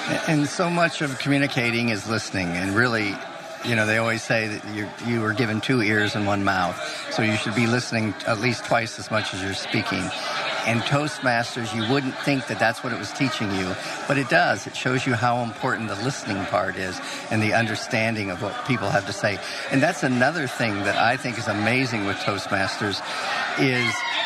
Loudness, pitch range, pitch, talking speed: -23 LUFS, 105-130 Hz, 115 Hz, 200 wpm